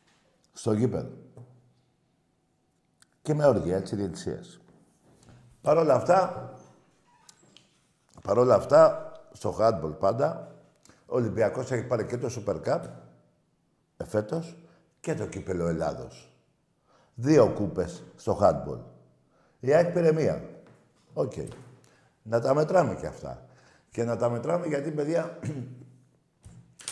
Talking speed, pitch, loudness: 110 wpm, 125 Hz, -27 LUFS